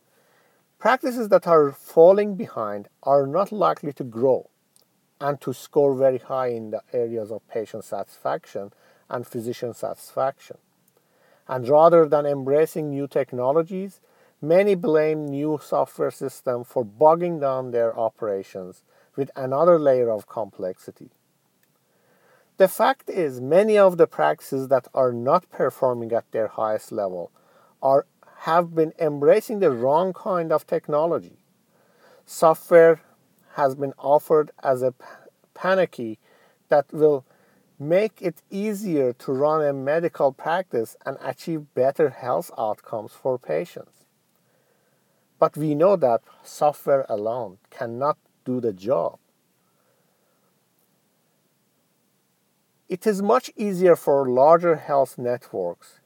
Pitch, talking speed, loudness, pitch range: 145 Hz, 120 wpm, -22 LUFS, 130-170 Hz